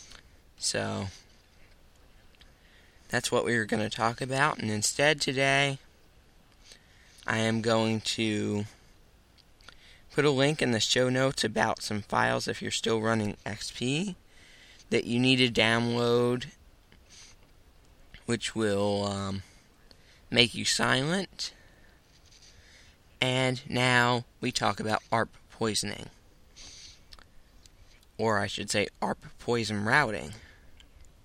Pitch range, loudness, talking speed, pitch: 95-120 Hz, -28 LUFS, 110 wpm, 110 Hz